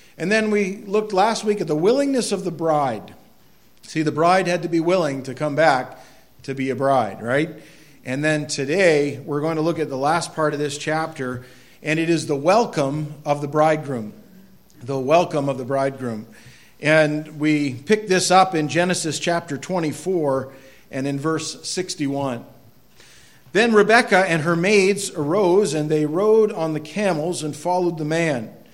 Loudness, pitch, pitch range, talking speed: -20 LUFS, 155 Hz, 140-180 Hz, 175 wpm